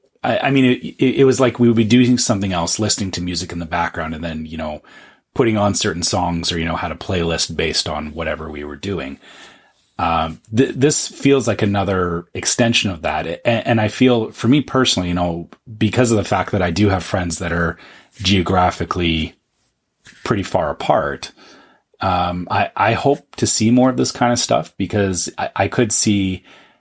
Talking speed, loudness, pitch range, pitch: 200 wpm, -17 LUFS, 85-115 Hz, 95 Hz